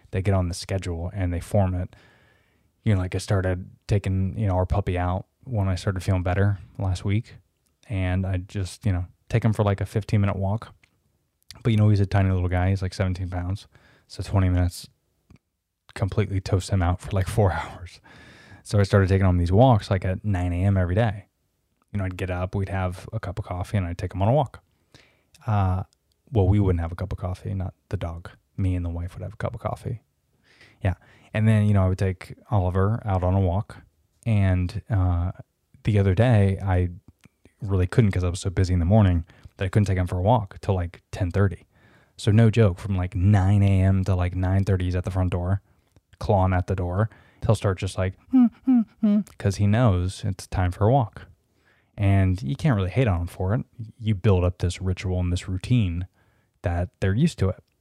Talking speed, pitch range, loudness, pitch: 220 wpm, 90-105 Hz, -24 LUFS, 95 Hz